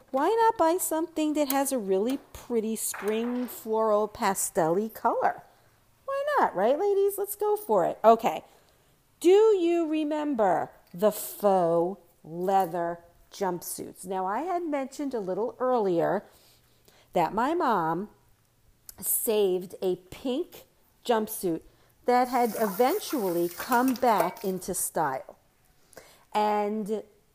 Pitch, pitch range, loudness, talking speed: 230 Hz, 195-300 Hz, -27 LUFS, 110 wpm